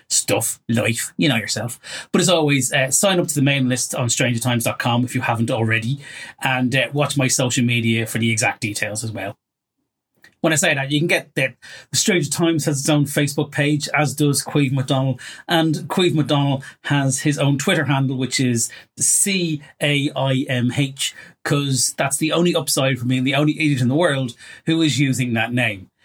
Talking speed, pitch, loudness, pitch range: 200 wpm, 135 Hz, -19 LUFS, 125-150 Hz